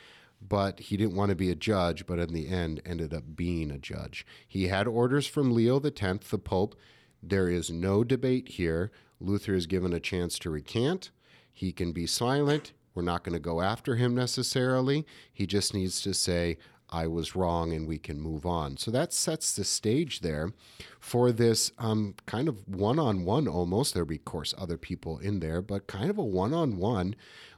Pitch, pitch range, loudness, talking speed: 100 Hz, 85-120 Hz, -30 LUFS, 200 wpm